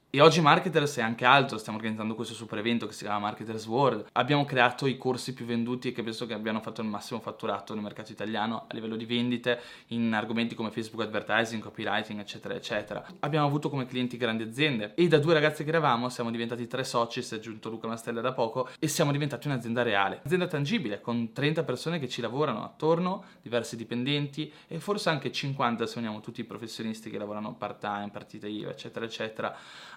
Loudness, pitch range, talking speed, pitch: -29 LUFS, 110-140 Hz, 200 wpm, 120 Hz